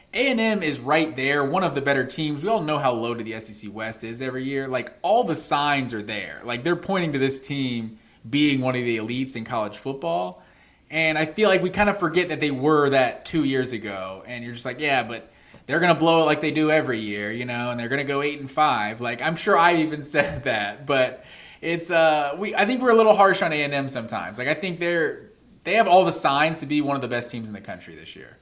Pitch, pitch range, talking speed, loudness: 145 Hz, 120-165 Hz, 255 wpm, -22 LUFS